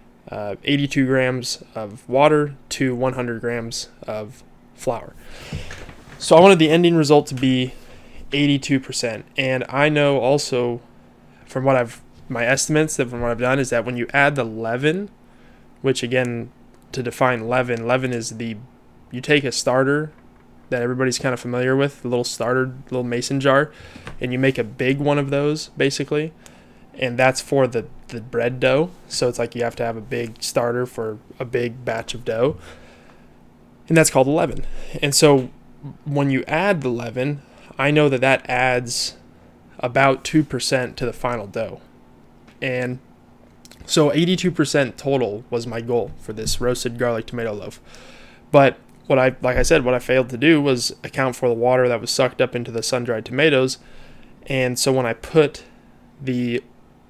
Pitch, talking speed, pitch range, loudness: 125 Hz, 170 wpm, 120-140 Hz, -20 LUFS